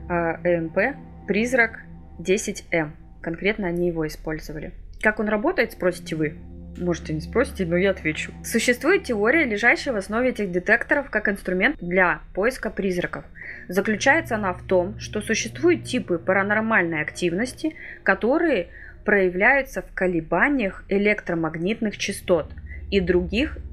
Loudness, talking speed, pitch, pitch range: -23 LUFS, 120 wpm, 190 Hz, 170-215 Hz